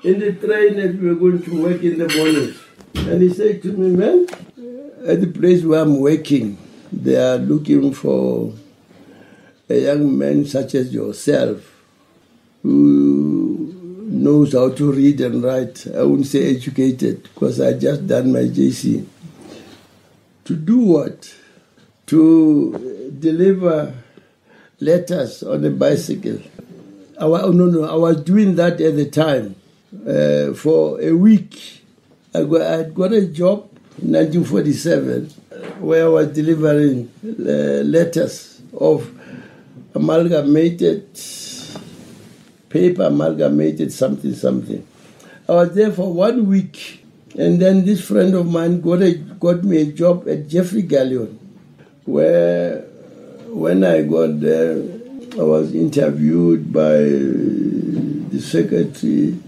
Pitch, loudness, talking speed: 160 Hz, -16 LUFS, 125 wpm